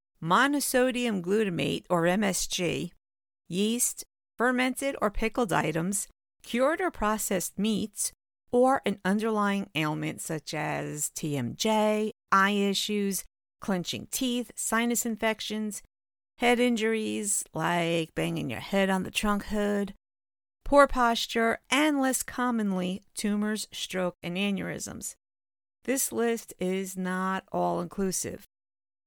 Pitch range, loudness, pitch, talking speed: 175-230 Hz, -28 LUFS, 200 Hz, 105 wpm